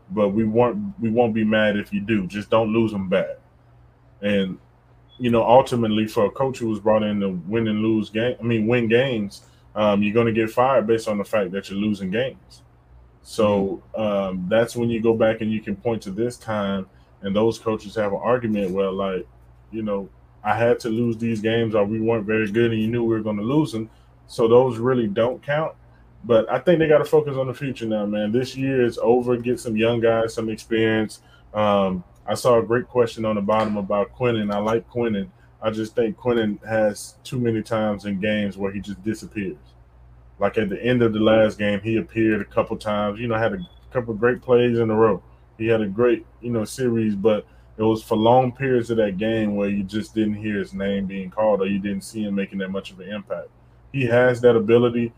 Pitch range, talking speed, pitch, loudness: 100-115 Hz, 225 wpm, 110 Hz, -22 LUFS